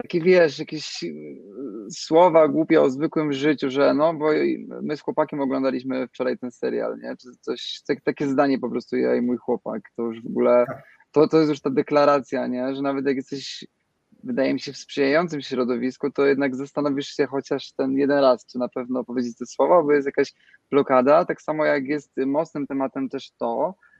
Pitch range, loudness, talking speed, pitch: 125-150 Hz, -22 LUFS, 195 wpm, 140 Hz